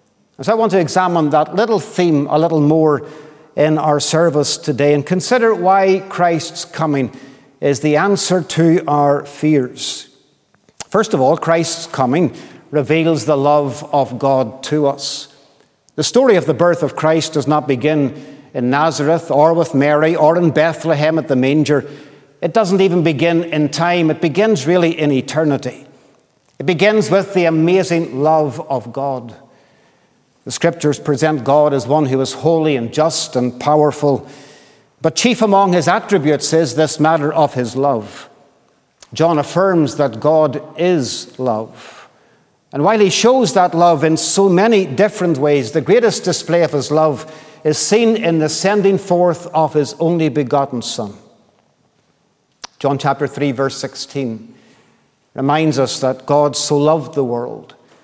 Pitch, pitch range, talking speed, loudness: 155 Hz, 140-170 Hz, 155 wpm, -15 LUFS